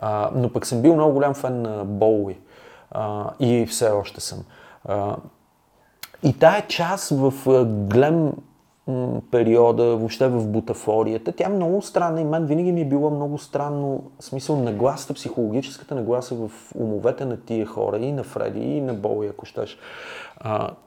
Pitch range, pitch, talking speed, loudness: 110-150 Hz, 125 Hz, 150 wpm, -22 LUFS